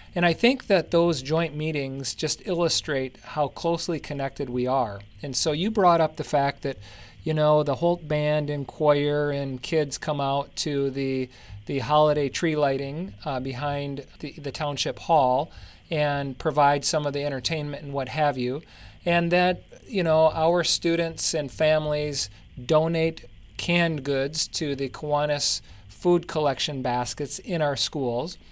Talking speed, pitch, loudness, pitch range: 160 wpm, 145 Hz, -25 LUFS, 135-160 Hz